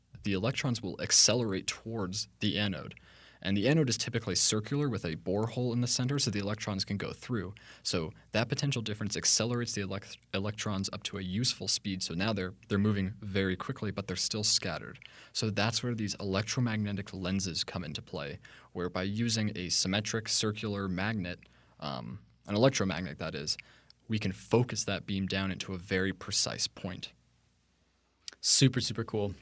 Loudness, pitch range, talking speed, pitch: -31 LUFS, 95-115 Hz, 170 wpm, 105 Hz